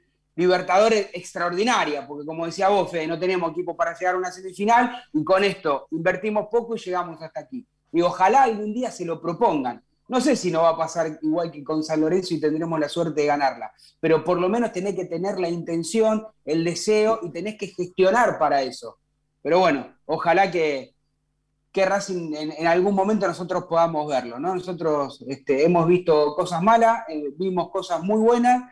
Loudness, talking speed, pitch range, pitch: -22 LUFS, 190 wpm, 160-200 Hz, 175 Hz